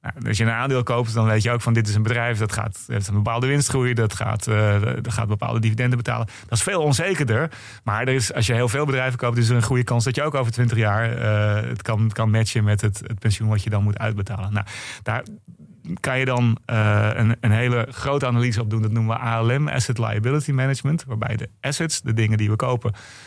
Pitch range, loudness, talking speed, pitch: 110-125 Hz, -22 LUFS, 250 wpm, 115 Hz